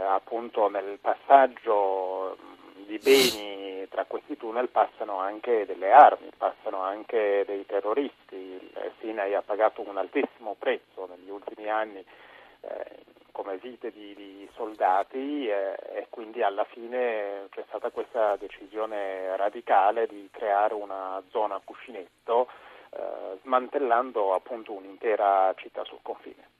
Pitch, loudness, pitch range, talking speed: 100 Hz, -27 LUFS, 95-115 Hz, 120 wpm